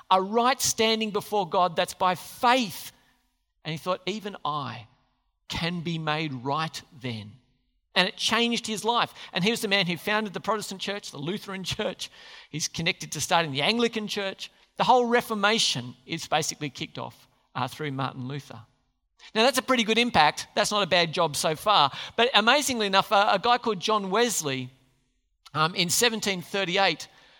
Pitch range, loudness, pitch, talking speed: 150-215 Hz, -25 LUFS, 185 Hz, 175 wpm